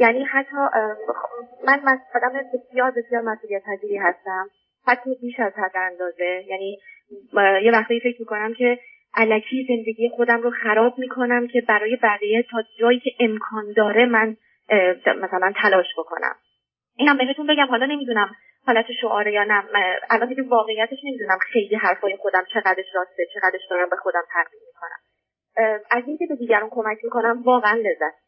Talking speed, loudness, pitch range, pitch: 155 wpm, -21 LUFS, 200-245 Hz, 225 Hz